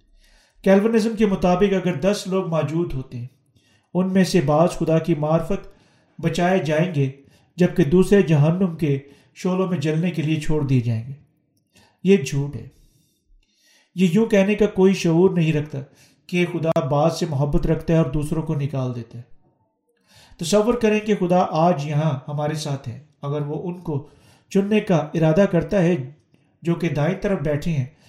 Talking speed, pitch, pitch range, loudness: 175 wpm, 160 Hz, 145-185 Hz, -21 LUFS